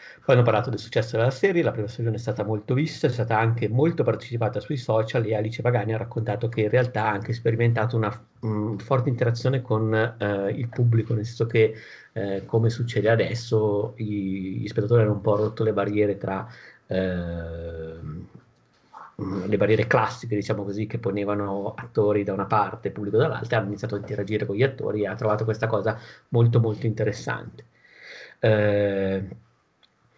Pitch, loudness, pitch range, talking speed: 110 Hz, -25 LUFS, 105-120 Hz, 175 wpm